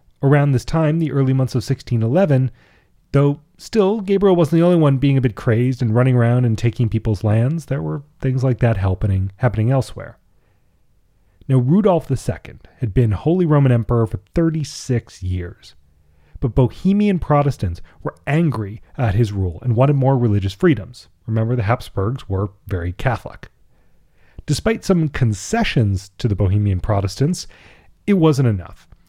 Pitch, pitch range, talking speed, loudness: 125 Hz, 105-145 Hz, 150 wpm, -18 LUFS